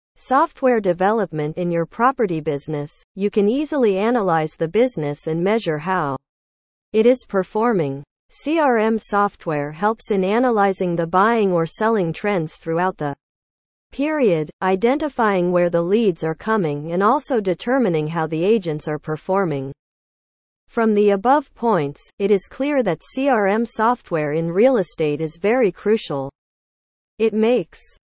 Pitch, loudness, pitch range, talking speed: 190 Hz, -20 LUFS, 155-225 Hz, 135 wpm